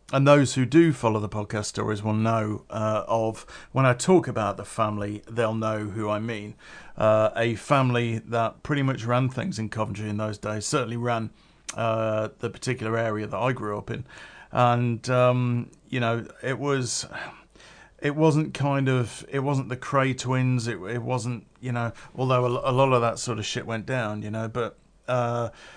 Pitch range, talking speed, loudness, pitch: 110-130 Hz, 190 wpm, -25 LUFS, 120 Hz